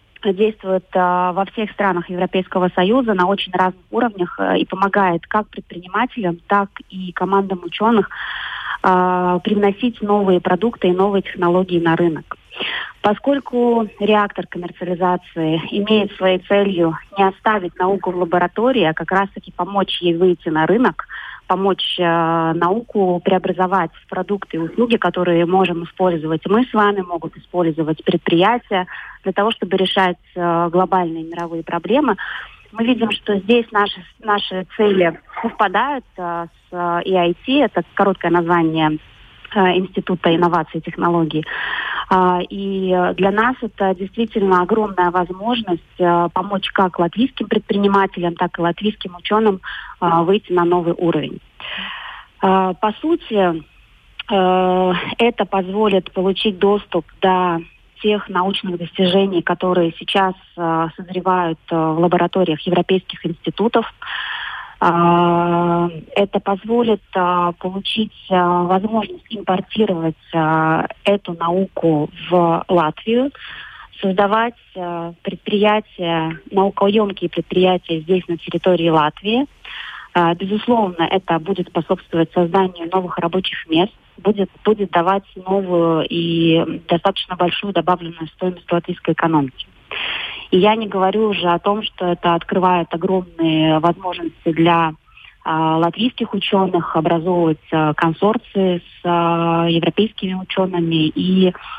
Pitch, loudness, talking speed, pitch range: 185 Hz, -18 LUFS, 110 wpm, 170-200 Hz